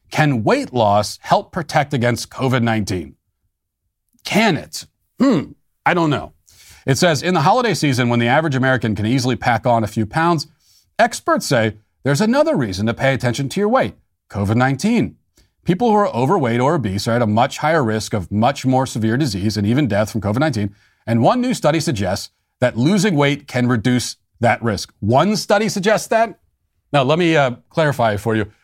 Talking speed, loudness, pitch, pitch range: 190 wpm, -17 LUFS, 125 Hz, 110-160 Hz